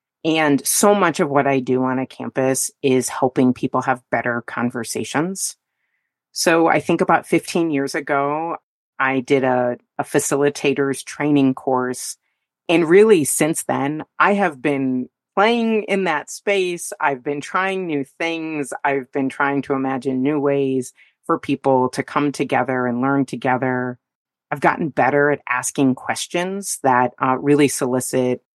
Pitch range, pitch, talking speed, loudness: 130-160 Hz, 140 Hz, 150 wpm, -19 LUFS